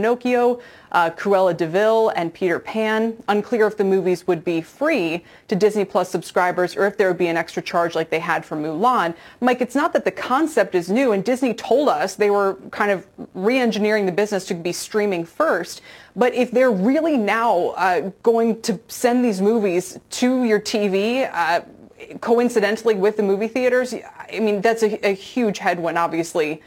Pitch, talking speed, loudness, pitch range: 205 Hz, 185 wpm, -20 LUFS, 180-235 Hz